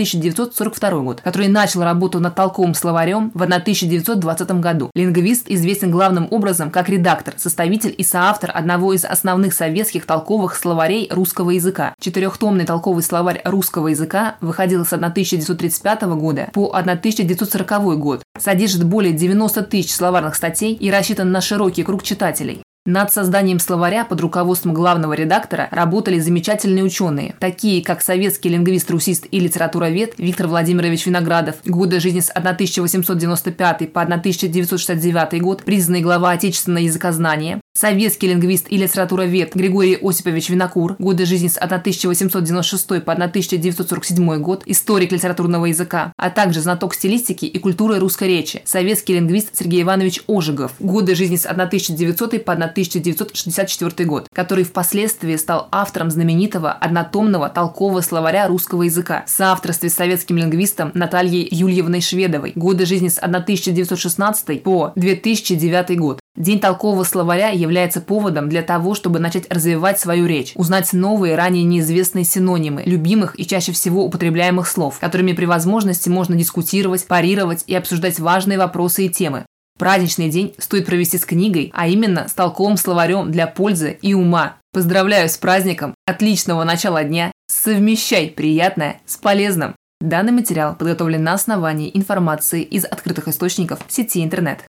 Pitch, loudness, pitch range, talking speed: 180 Hz, -17 LUFS, 170-195 Hz, 135 wpm